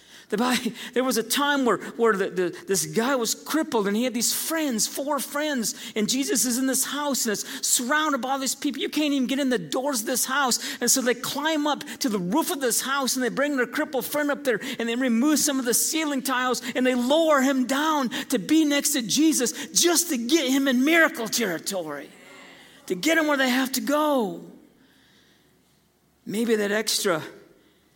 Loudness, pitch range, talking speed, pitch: -23 LUFS, 240-290 Hz, 210 wpm, 265 Hz